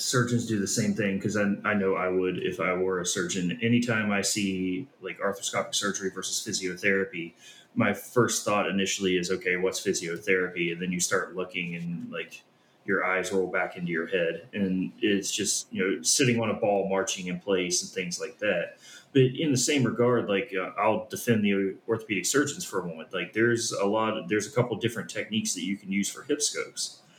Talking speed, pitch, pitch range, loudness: 210 wpm, 95 Hz, 90-110 Hz, -27 LUFS